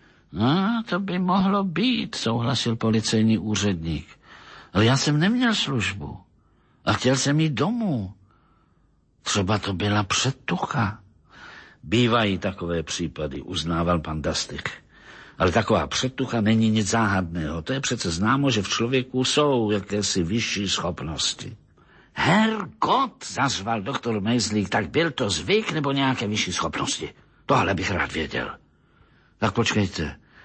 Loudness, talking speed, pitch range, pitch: -23 LUFS, 125 wpm, 100-140 Hz, 115 Hz